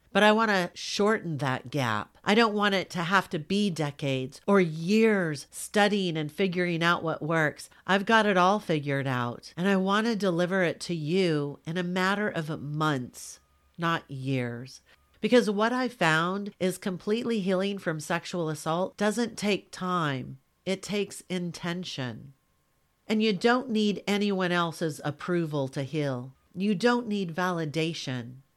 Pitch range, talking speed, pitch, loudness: 150-200 Hz, 155 wpm, 180 Hz, -27 LUFS